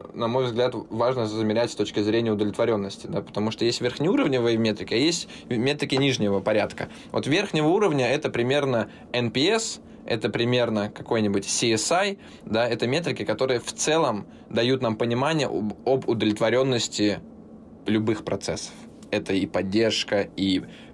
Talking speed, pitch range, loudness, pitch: 135 wpm, 105-125 Hz, -24 LUFS, 115 Hz